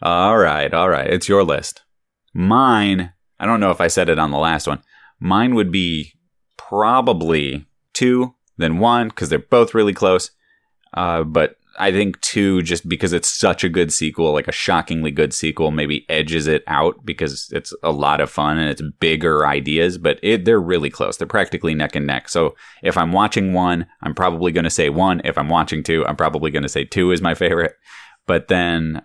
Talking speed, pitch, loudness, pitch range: 200 wpm, 85 Hz, -18 LUFS, 80-95 Hz